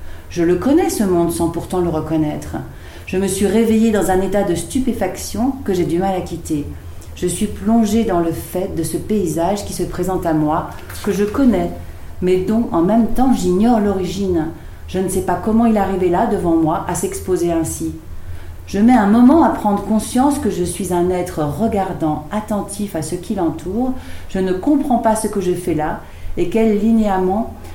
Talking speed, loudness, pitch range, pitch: 200 wpm, -17 LUFS, 165-215 Hz, 185 Hz